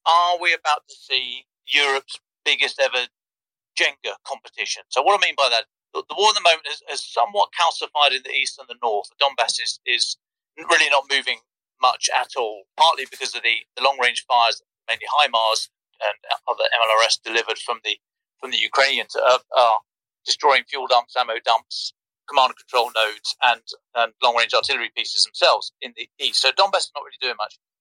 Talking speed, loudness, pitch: 185 wpm, -20 LUFS, 170 Hz